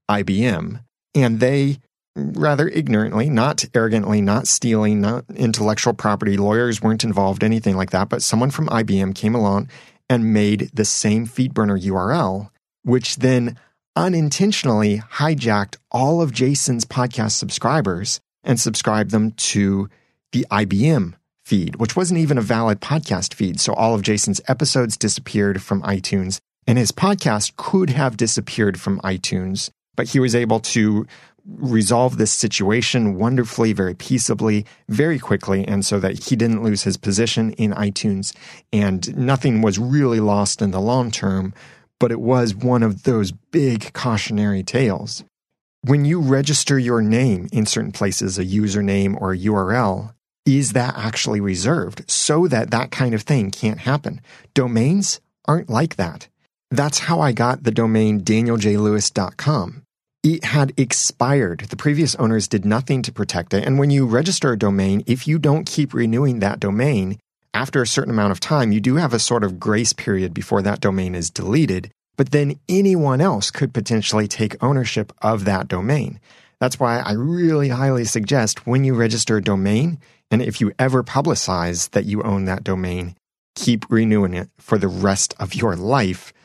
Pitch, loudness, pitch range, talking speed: 115 Hz, -19 LUFS, 105-130 Hz, 160 wpm